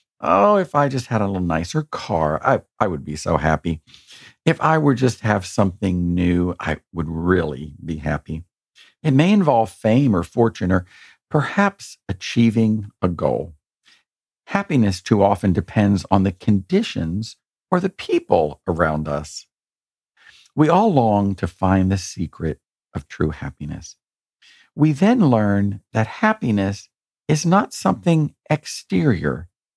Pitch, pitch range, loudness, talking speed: 100 Hz, 90-145 Hz, -20 LUFS, 140 wpm